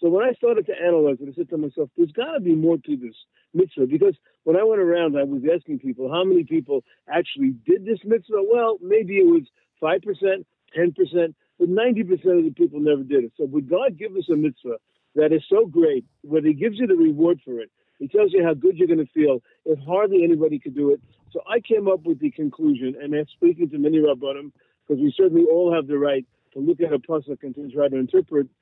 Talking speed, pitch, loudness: 235 wpm, 195 Hz, -21 LUFS